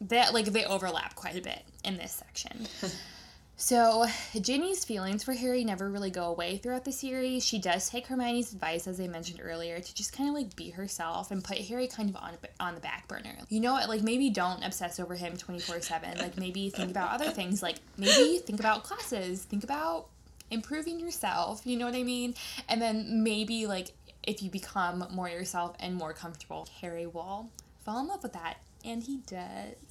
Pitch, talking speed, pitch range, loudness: 210 Hz, 205 wpm, 180-245 Hz, -32 LUFS